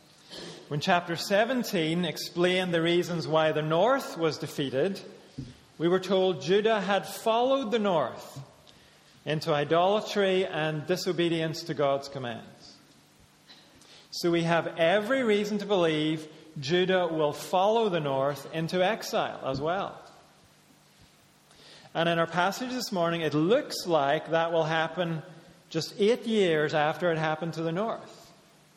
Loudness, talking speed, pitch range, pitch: -27 LUFS, 130 wpm, 155-190 Hz, 170 Hz